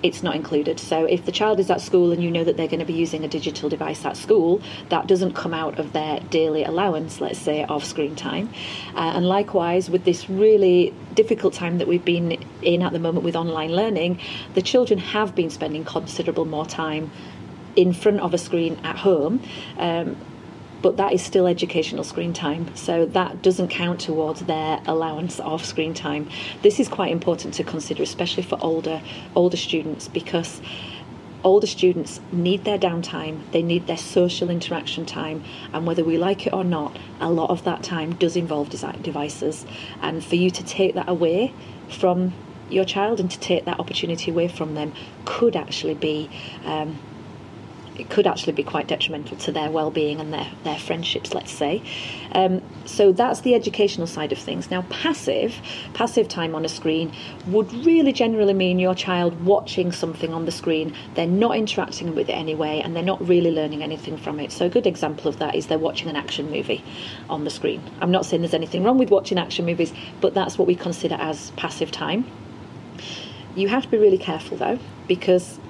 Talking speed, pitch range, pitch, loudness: 195 wpm, 160-185 Hz, 170 Hz, -22 LUFS